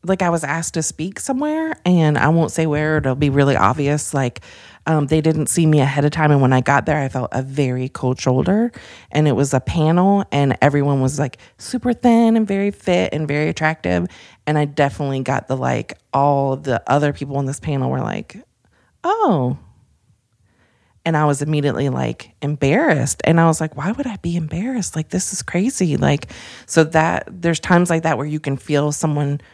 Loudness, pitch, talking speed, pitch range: -18 LUFS, 150 Hz, 205 wpm, 135-165 Hz